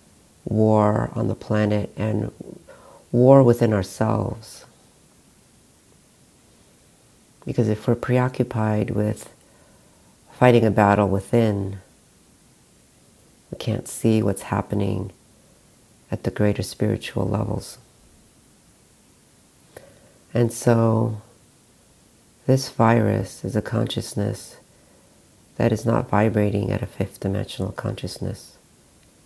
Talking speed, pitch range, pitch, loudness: 90 wpm, 105-120 Hz, 110 Hz, -22 LUFS